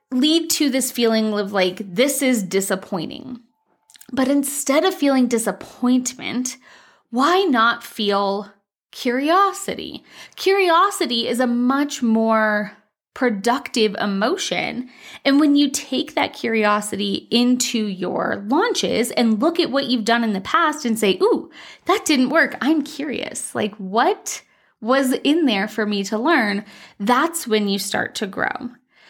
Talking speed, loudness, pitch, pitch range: 135 wpm, -19 LUFS, 250 Hz, 220-295 Hz